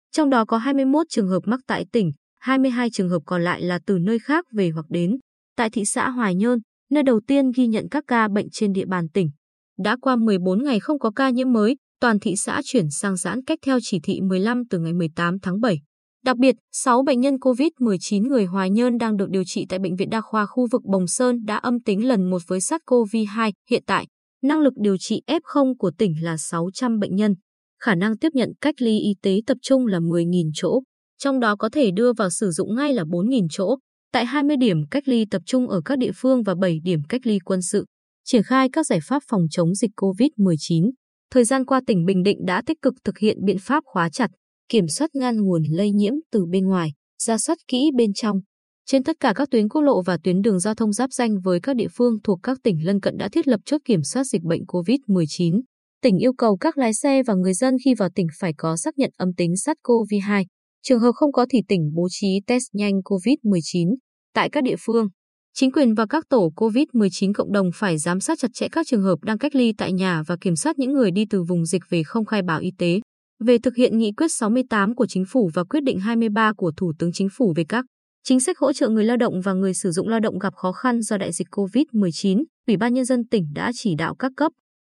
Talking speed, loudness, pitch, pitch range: 240 wpm, -21 LUFS, 220 Hz, 190-255 Hz